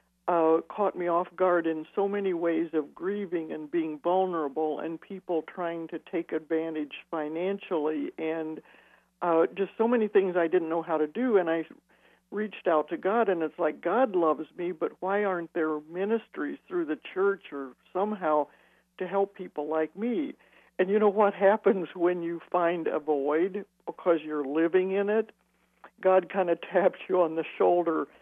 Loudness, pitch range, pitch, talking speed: -28 LUFS, 160-195 Hz, 175 Hz, 175 wpm